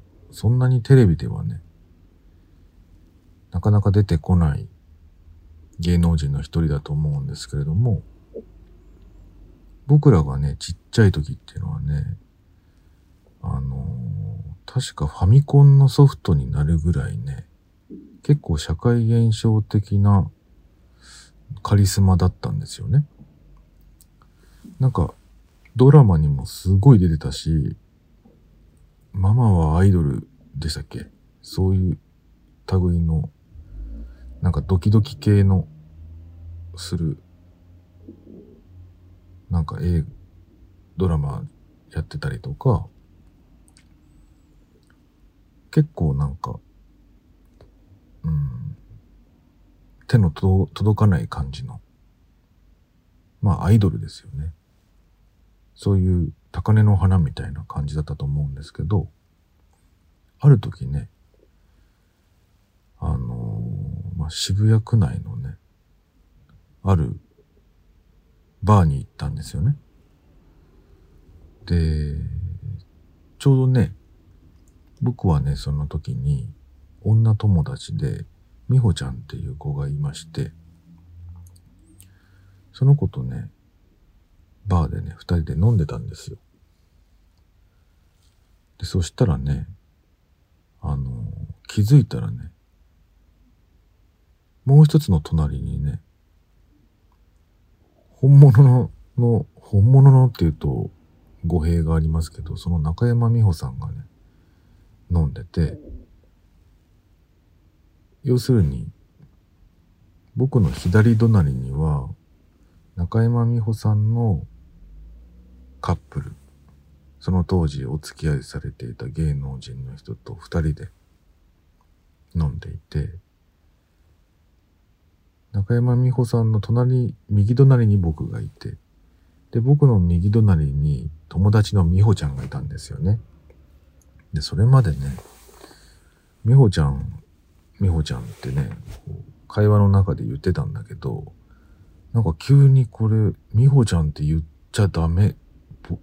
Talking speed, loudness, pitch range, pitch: 195 characters per minute, -20 LUFS, 80-105 Hz, 85 Hz